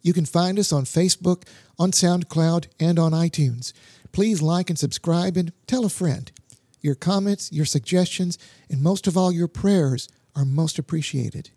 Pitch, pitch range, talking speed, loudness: 165 Hz, 145-180 Hz, 165 wpm, -22 LUFS